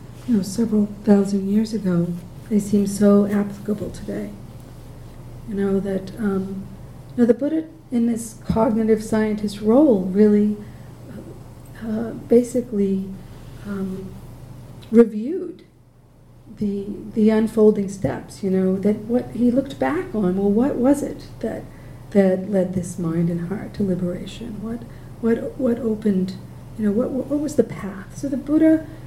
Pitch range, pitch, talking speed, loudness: 190-235 Hz, 210 Hz, 140 wpm, -21 LUFS